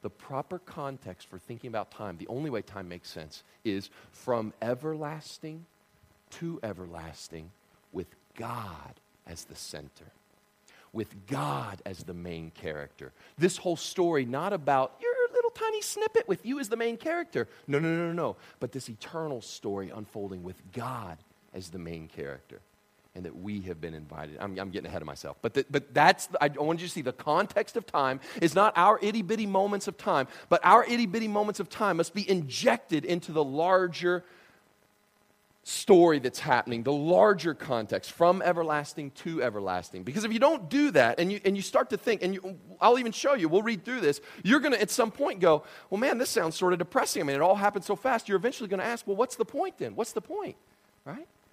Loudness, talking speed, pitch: -28 LUFS, 200 wpm, 170 Hz